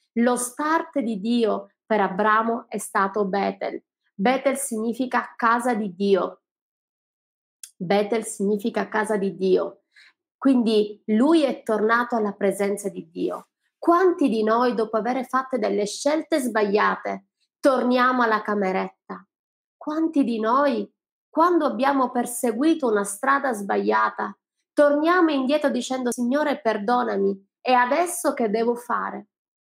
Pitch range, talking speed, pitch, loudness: 210-275 Hz, 115 wpm, 235 Hz, -23 LUFS